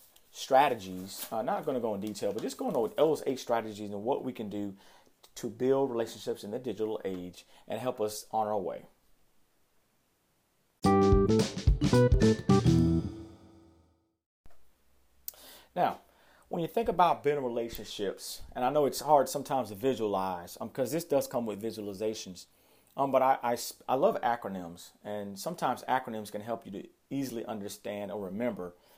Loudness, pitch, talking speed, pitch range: -31 LUFS, 110 Hz, 150 wpm, 100-125 Hz